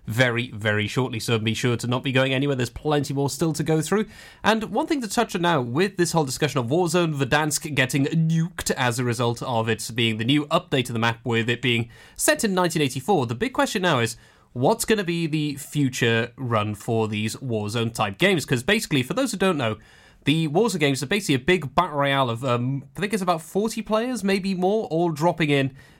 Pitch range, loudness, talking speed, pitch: 120-180 Hz, -23 LUFS, 225 wpm, 145 Hz